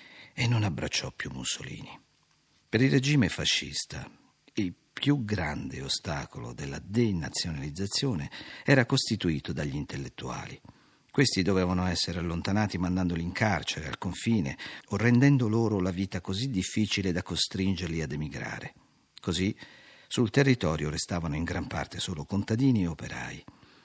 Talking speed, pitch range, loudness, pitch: 125 wpm, 85-120 Hz, -29 LUFS, 100 Hz